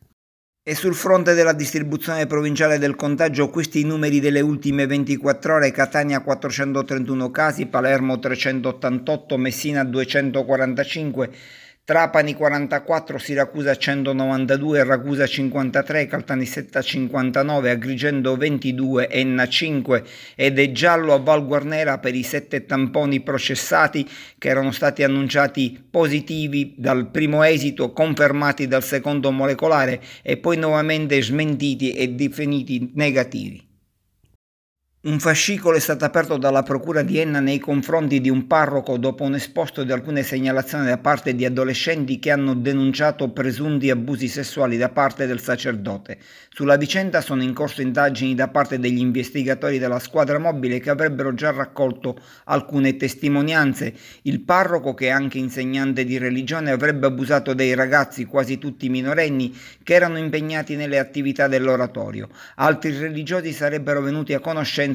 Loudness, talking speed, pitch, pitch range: -20 LUFS, 130 wpm, 140 Hz, 130-150 Hz